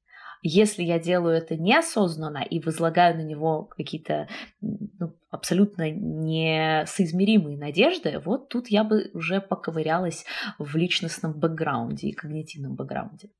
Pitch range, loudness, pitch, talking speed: 160-205 Hz, -25 LUFS, 170 Hz, 115 wpm